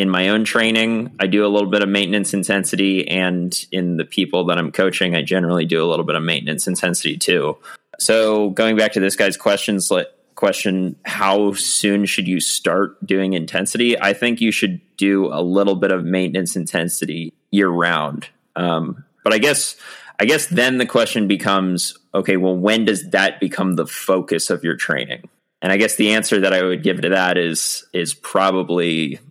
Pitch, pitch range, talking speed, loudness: 95 Hz, 90-105 Hz, 190 wpm, -18 LUFS